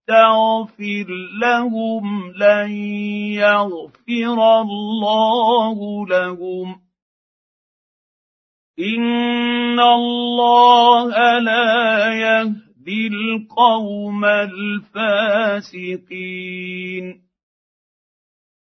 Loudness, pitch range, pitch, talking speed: -16 LUFS, 205-230 Hz, 215 Hz, 40 wpm